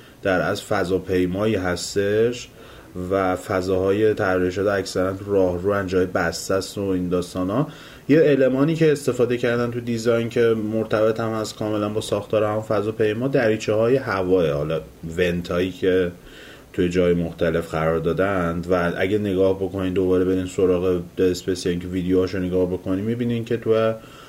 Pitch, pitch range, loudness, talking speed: 95 Hz, 90-110 Hz, -22 LUFS, 155 wpm